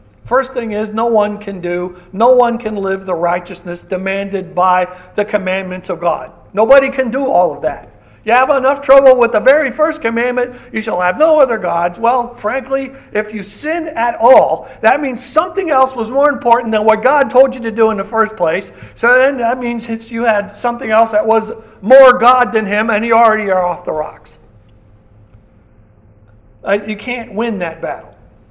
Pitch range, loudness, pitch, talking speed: 180-250 Hz, -13 LUFS, 220 Hz, 195 wpm